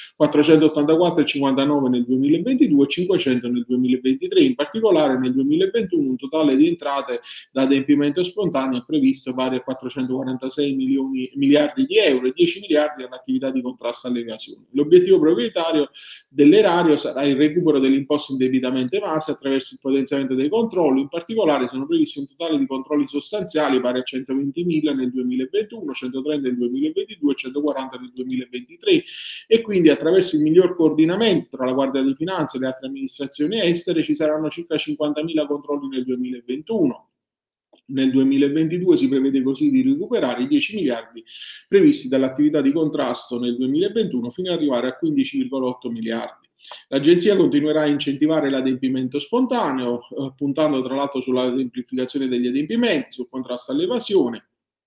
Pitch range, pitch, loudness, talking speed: 130-170 Hz, 140 Hz, -20 LUFS, 145 wpm